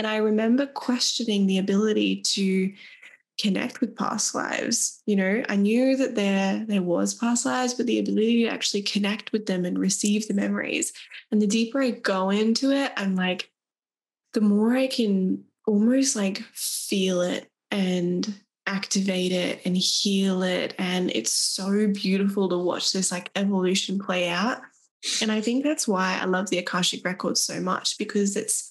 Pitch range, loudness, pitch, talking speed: 190-230 Hz, -24 LUFS, 205 Hz, 170 wpm